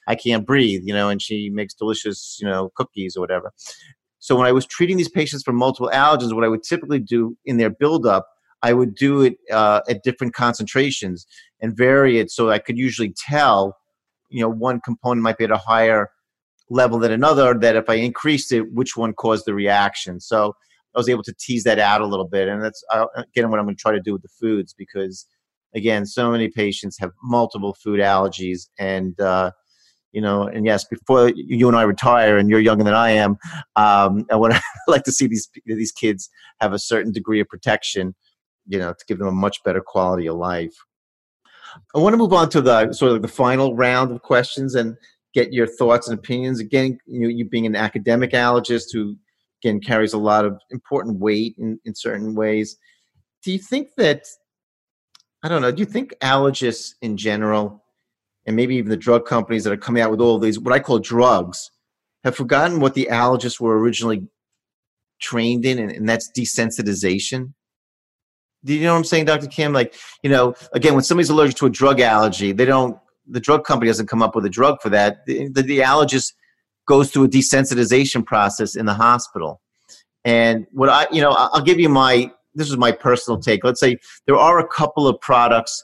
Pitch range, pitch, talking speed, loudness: 105-130 Hz, 115 Hz, 205 wpm, -18 LUFS